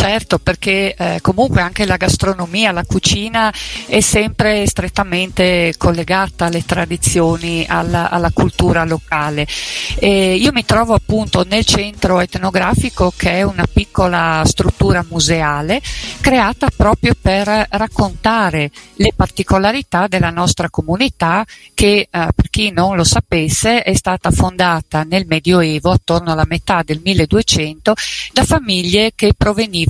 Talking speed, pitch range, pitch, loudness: 125 wpm, 165-205 Hz, 180 Hz, -14 LUFS